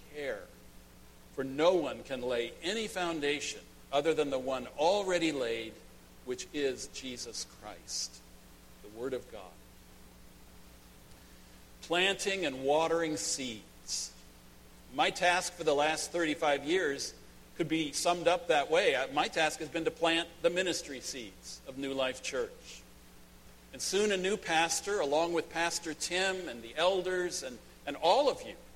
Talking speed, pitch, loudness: 145 wpm, 145 Hz, -32 LUFS